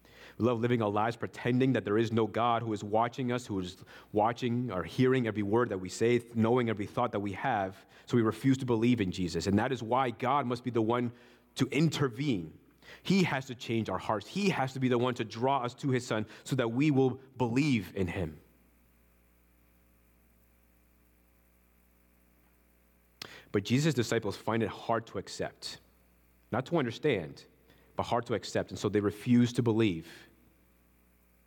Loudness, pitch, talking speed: -31 LUFS, 110 Hz, 180 wpm